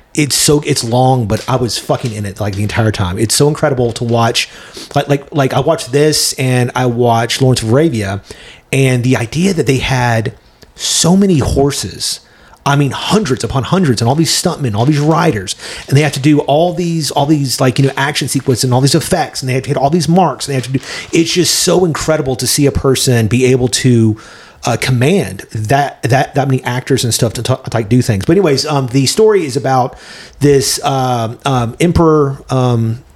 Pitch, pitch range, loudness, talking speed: 135 Hz, 120-150 Hz, -12 LUFS, 220 wpm